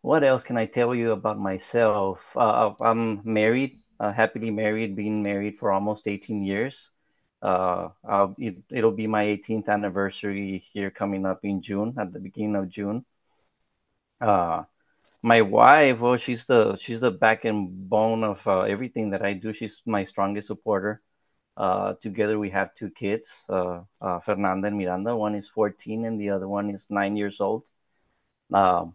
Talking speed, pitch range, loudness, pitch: 170 wpm, 100-110 Hz, -25 LUFS, 105 Hz